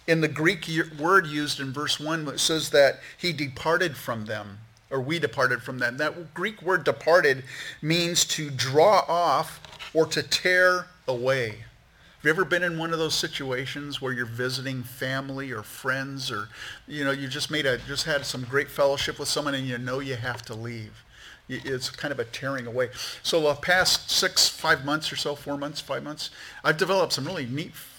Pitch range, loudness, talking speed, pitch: 130-160 Hz, -25 LUFS, 195 wpm, 145 Hz